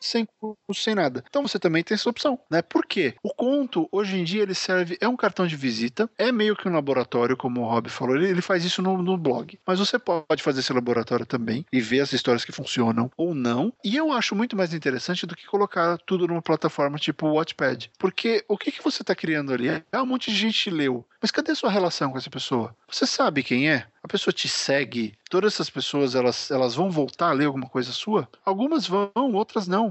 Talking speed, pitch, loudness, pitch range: 235 wpm, 175 Hz, -24 LUFS, 135-210 Hz